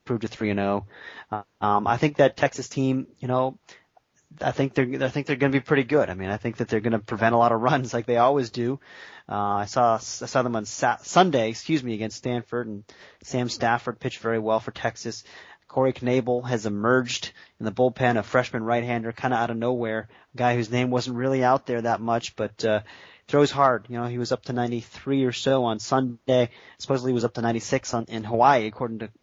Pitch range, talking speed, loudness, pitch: 115-130 Hz, 235 wpm, -25 LUFS, 120 Hz